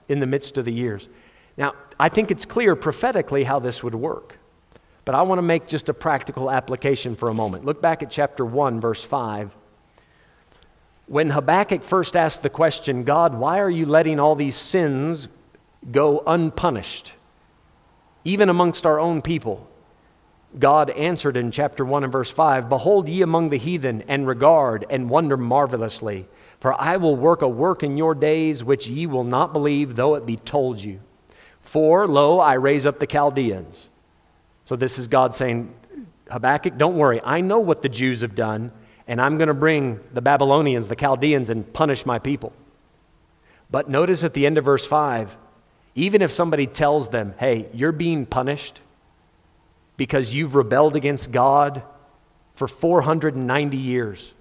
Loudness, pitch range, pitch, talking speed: -20 LUFS, 125-155 Hz, 140 Hz, 170 wpm